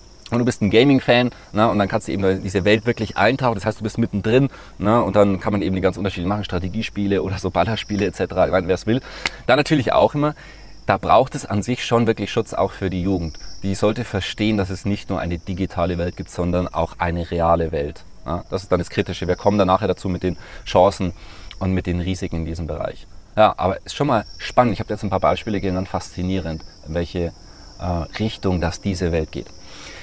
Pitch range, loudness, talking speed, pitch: 90-105 Hz, -21 LUFS, 225 wpm, 95 Hz